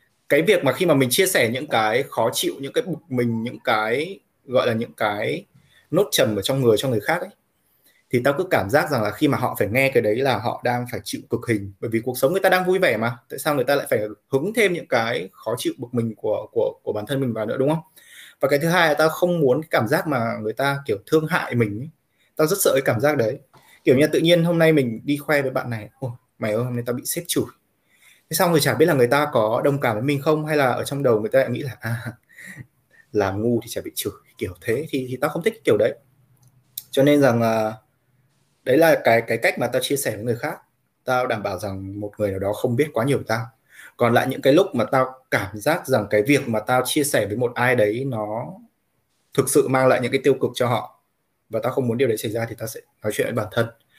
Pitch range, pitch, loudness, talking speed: 115-155 Hz, 130 Hz, -21 LUFS, 280 wpm